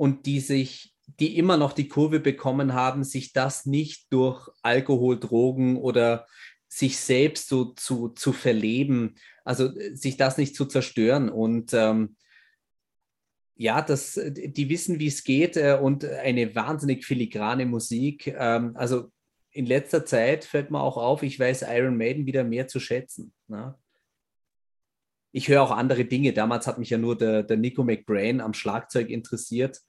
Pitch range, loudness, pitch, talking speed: 120-140 Hz, -25 LUFS, 130 Hz, 155 wpm